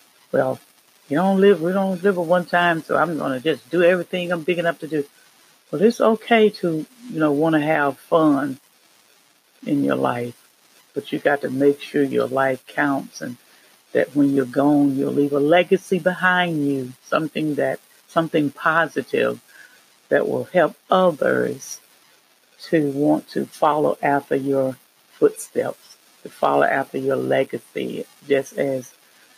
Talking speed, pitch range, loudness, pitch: 155 wpm, 140-180 Hz, -20 LUFS, 155 Hz